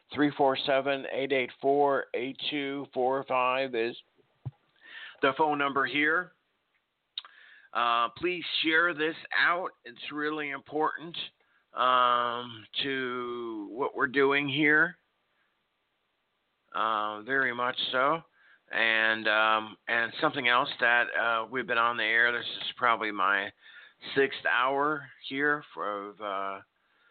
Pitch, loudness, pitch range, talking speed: 135 Hz, -28 LUFS, 120-145 Hz, 95 wpm